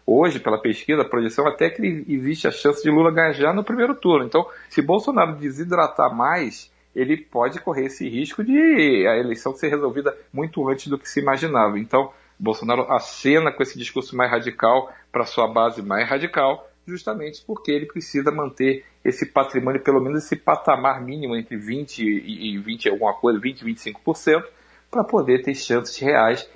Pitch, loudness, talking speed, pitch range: 135 Hz, -21 LUFS, 170 wpm, 120-155 Hz